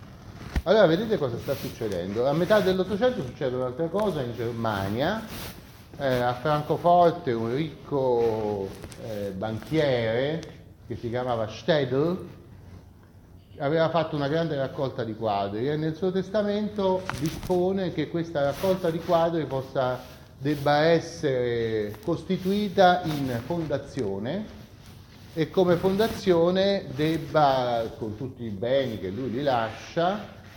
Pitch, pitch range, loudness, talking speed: 140 Hz, 115-170 Hz, -26 LUFS, 115 wpm